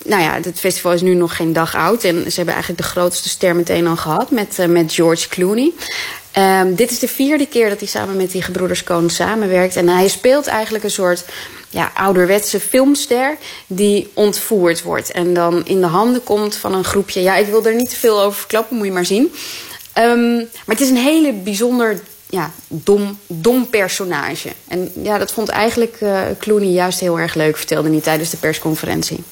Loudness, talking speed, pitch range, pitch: -15 LUFS, 205 wpm, 175-220 Hz, 195 Hz